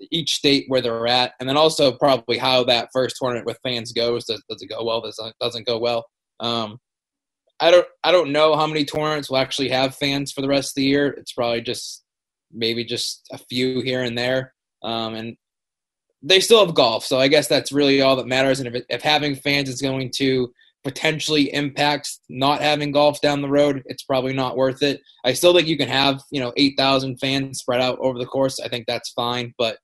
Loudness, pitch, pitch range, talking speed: -20 LUFS, 130 Hz, 125-145 Hz, 225 wpm